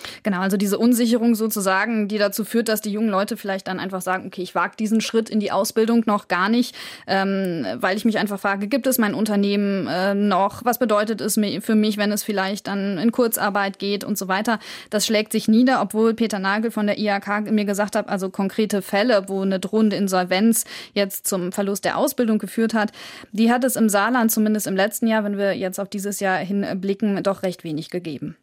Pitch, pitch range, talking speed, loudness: 205 Hz, 195-220 Hz, 215 wpm, -21 LUFS